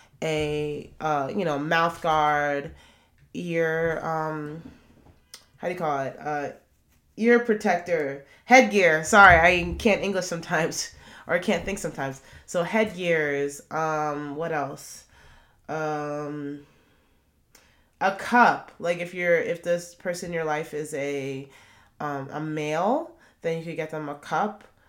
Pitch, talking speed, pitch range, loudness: 155 Hz, 135 wpm, 145-175 Hz, -24 LUFS